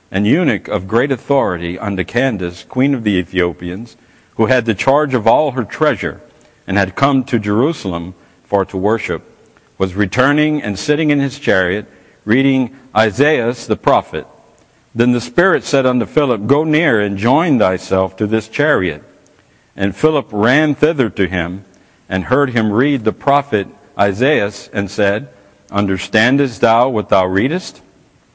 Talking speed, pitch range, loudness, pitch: 150 wpm, 100-135 Hz, -15 LUFS, 115 Hz